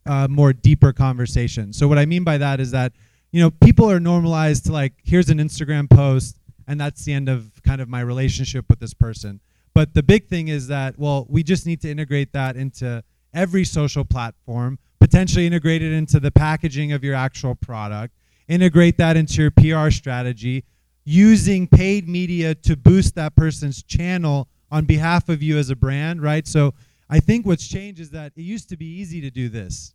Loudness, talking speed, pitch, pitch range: -18 LUFS, 200 wpm, 145 Hz, 130-160 Hz